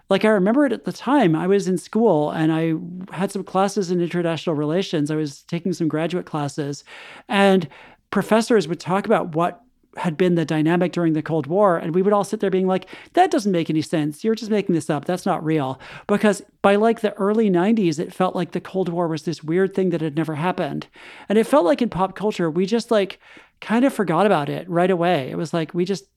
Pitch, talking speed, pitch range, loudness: 185 Hz, 235 wpm, 165-205 Hz, -21 LUFS